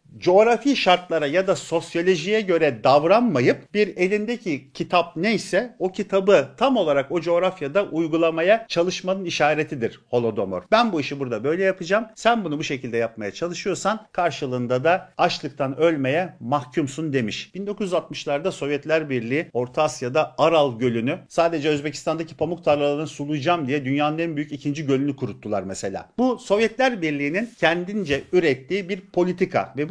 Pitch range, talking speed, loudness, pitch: 145-190 Hz, 135 wpm, -22 LUFS, 165 Hz